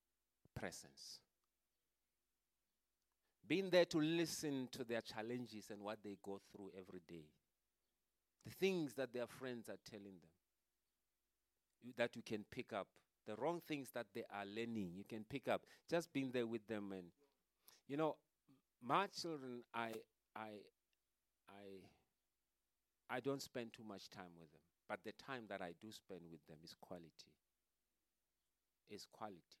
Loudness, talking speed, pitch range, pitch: -47 LUFS, 150 wpm, 95-130 Hz, 110 Hz